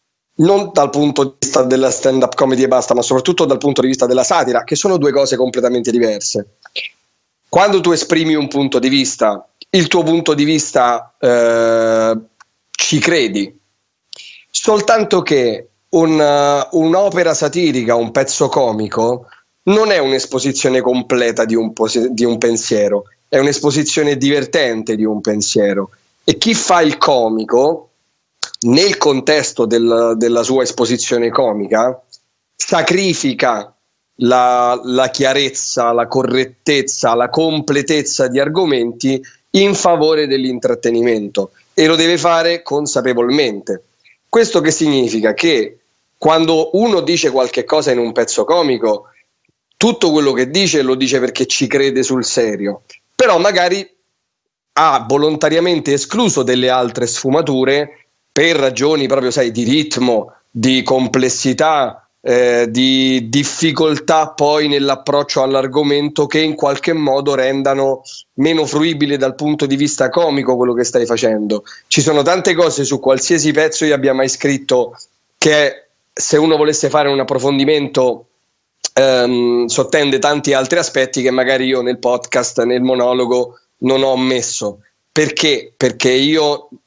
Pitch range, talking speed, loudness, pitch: 125-155 Hz, 135 wpm, -14 LUFS, 135 Hz